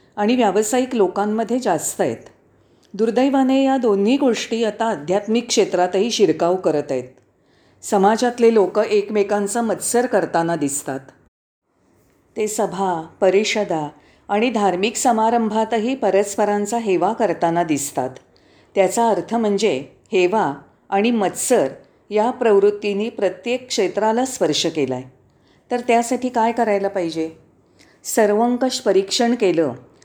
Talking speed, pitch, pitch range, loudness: 105 wpm, 205 Hz, 180-230 Hz, -19 LUFS